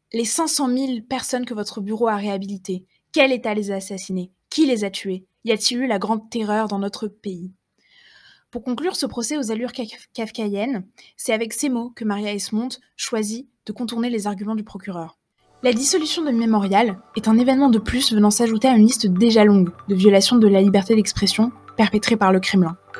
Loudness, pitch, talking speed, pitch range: -20 LUFS, 220 Hz, 195 wpm, 200-245 Hz